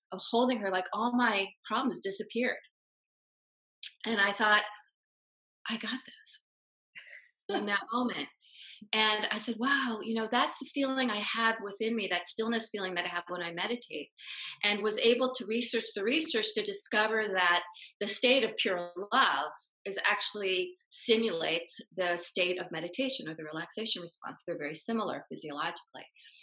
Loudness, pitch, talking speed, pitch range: -31 LUFS, 220 Hz, 155 wpm, 195-245 Hz